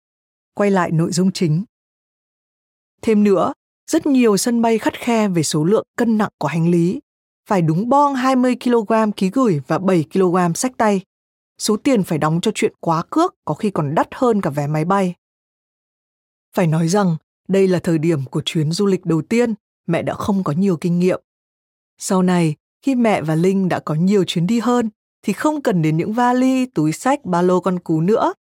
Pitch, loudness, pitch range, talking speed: 190 Hz, -18 LUFS, 170-230 Hz, 195 wpm